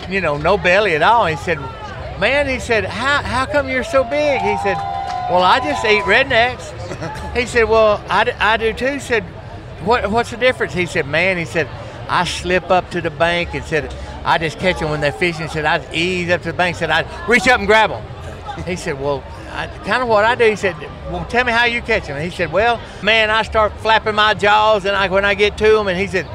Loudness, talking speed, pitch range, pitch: -16 LUFS, 250 wpm, 170-230 Hz, 200 Hz